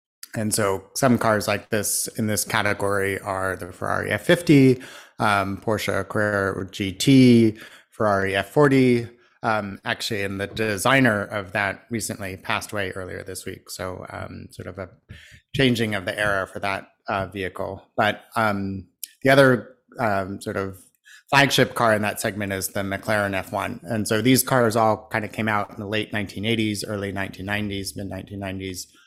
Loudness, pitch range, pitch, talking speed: -22 LUFS, 95-110 Hz, 105 Hz, 160 wpm